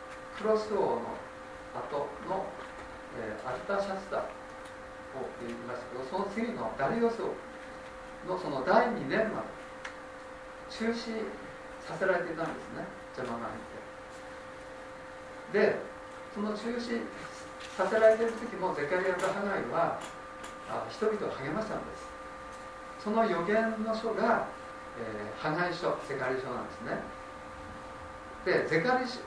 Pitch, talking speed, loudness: 75 Hz, 240 characters per minute, -33 LUFS